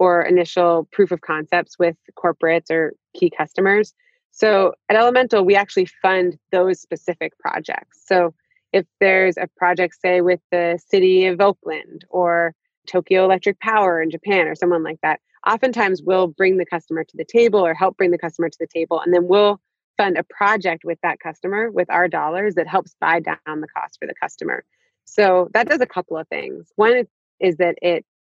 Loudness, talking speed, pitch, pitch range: -19 LUFS, 185 wpm, 180 Hz, 170-195 Hz